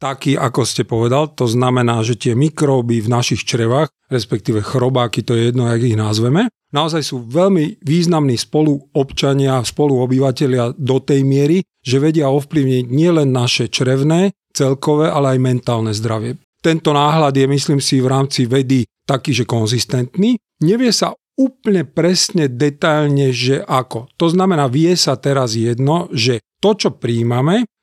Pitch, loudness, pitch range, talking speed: 135 Hz, -15 LUFS, 125-155 Hz, 145 wpm